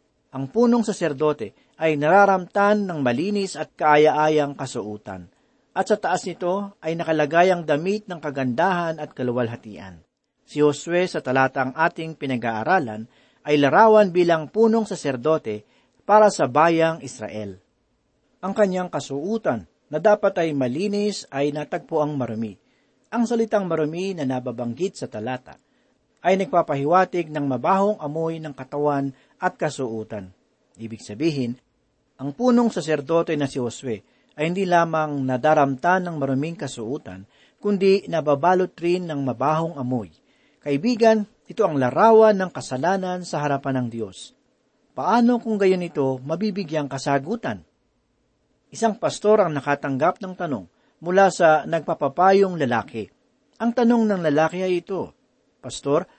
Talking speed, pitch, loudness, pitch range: 125 wpm, 160 Hz, -21 LUFS, 135-190 Hz